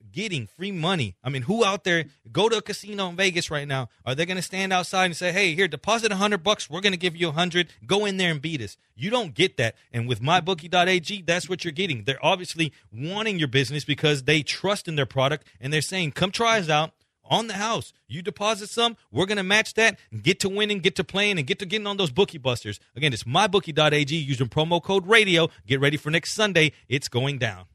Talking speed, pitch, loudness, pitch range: 235 wpm, 175 Hz, -23 LUFS, 145-195 Hz